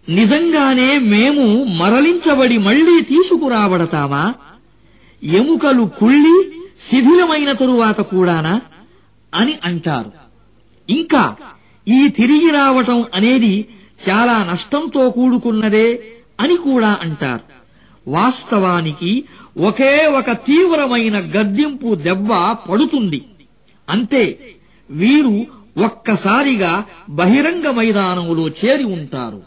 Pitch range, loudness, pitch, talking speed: 185-275 Hz, -14 LUFS, 230 Hz, 75 wpm